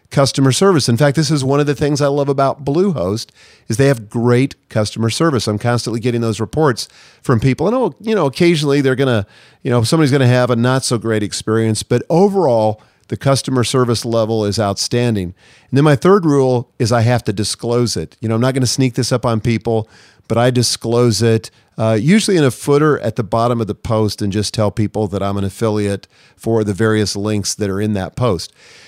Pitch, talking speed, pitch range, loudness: 120 Hz, 220 wpm, 110-135 Hz, -15 LUFS